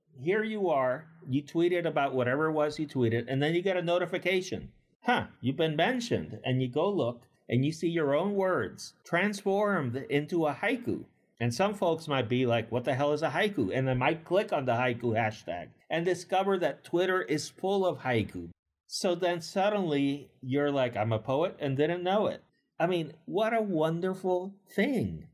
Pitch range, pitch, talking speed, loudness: 130-185 Hz, 155 Hz, 190 wpm, -30 LUFS